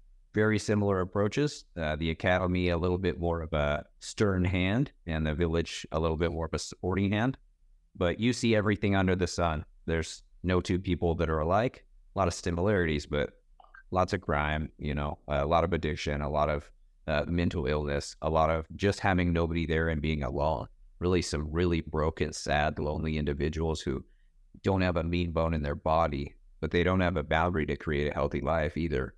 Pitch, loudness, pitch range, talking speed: 85 Hz, -30 LUFS, 75-90 Hz, 200 wpm